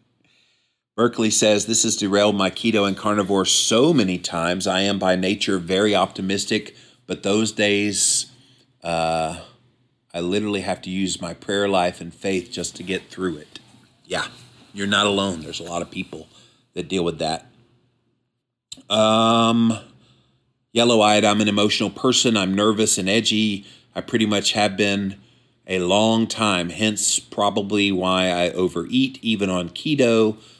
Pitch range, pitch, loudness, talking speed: 95-115 Hz, 105 Hz, -20 LUFS, 150 wpm